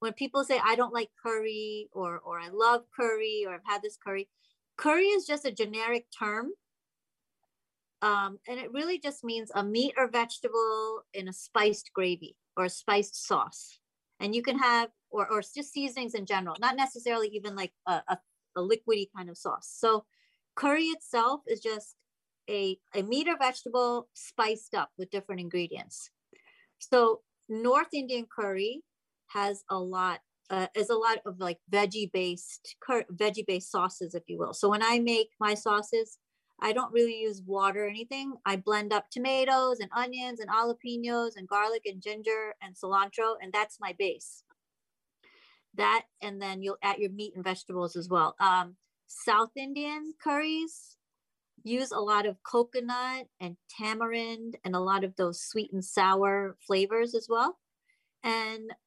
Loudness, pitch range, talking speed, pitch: -30 LUFS, 195-245 Hz, 165 wpm, 220 Hz